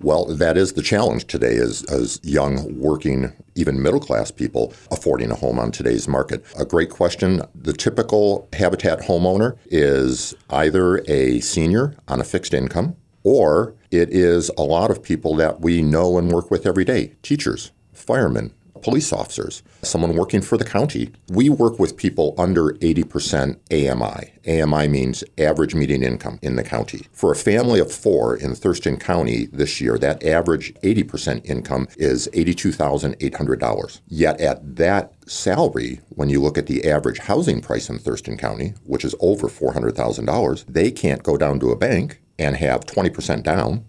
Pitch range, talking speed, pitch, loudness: 70-95 Hz, 165 wpm, 85 Hz, -20 LUFS